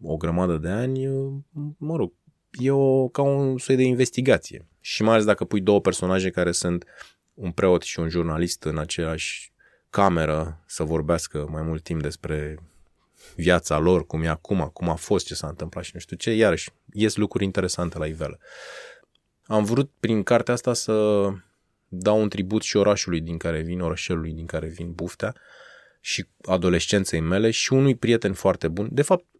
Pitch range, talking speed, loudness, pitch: 80-115 Hz, 175 wpm, -24 LUFS, 90 Hz